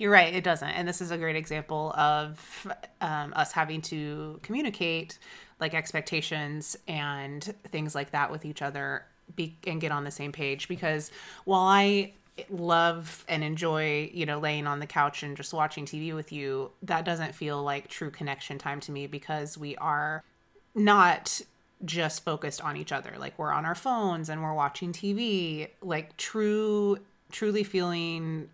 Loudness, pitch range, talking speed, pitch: -30 LUFS, 150-175 Hz, 170 wpm, 155 Hz